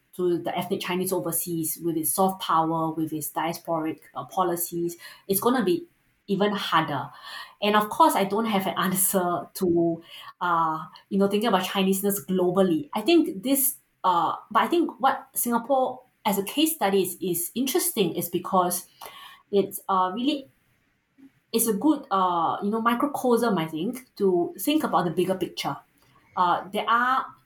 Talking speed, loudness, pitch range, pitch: 165 wpm, -25 LUFS, 175-235 Hz, 195 Hz